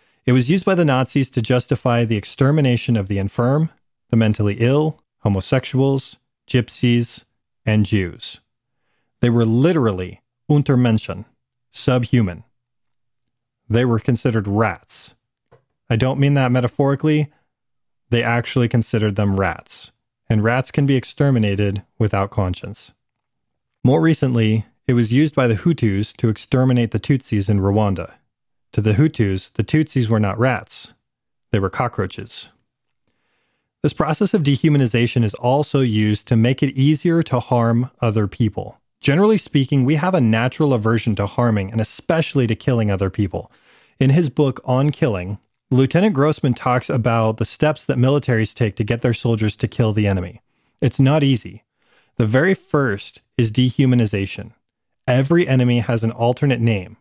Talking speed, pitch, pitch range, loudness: 145 wpm, 120 Hz, 110-135 Hz, -18 LUFS